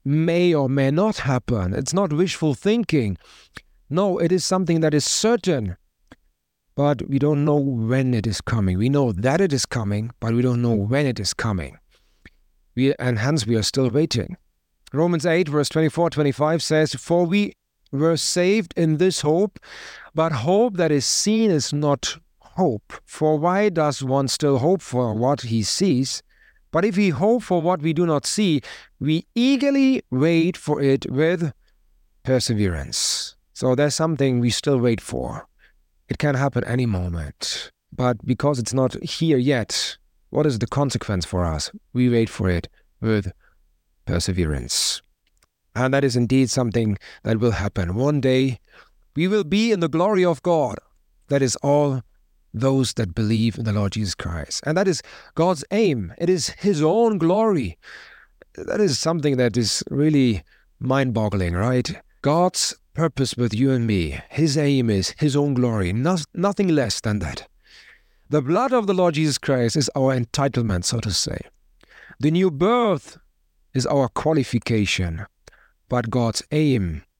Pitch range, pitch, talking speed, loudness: 115-165 Hz, 140 Hz, 165 wpm, -21 LUFS